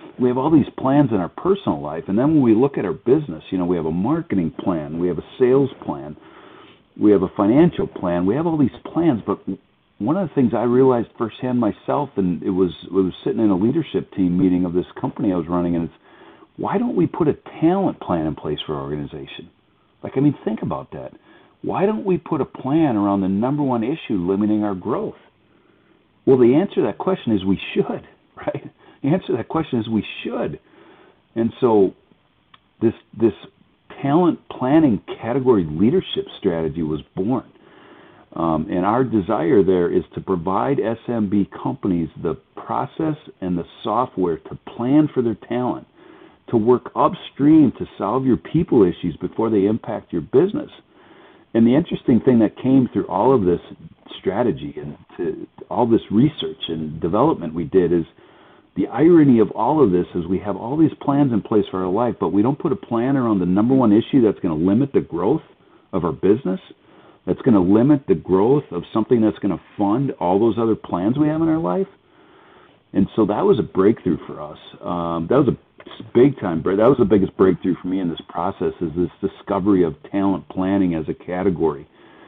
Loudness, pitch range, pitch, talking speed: -20 LUFS, 90-130 Hz, 105 Hz, 200 wpm